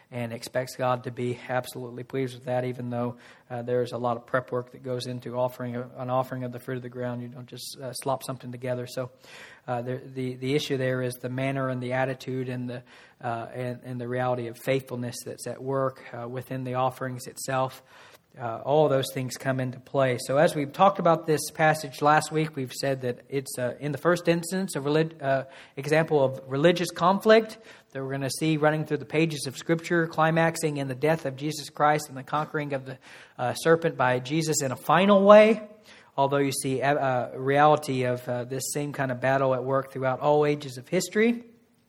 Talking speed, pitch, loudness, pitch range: 215 wpm, 135 Hz, -26 LUFS, 125-150 Hz